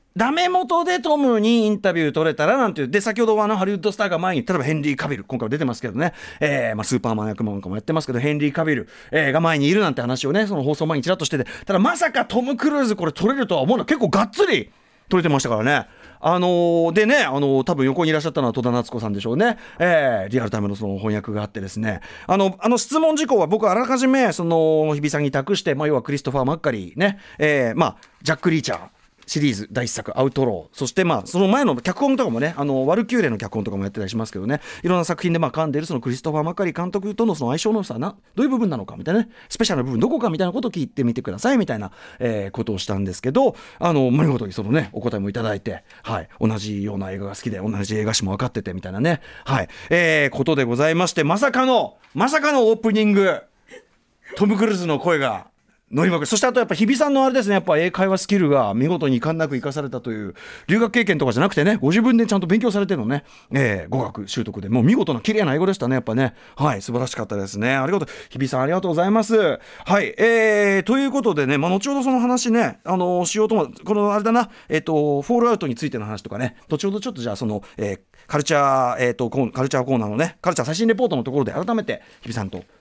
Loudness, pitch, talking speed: -20 LUFS, 155 Hz, 525 characters per minute